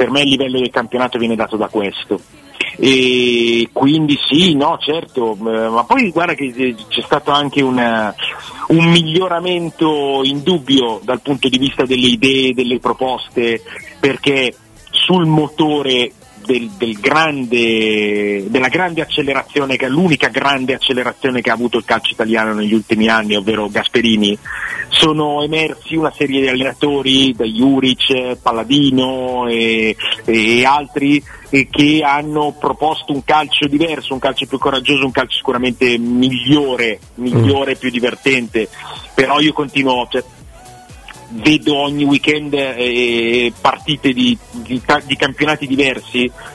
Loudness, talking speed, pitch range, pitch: -14 LUFS, 135 wpm, 120-145 Hz, 130 Hz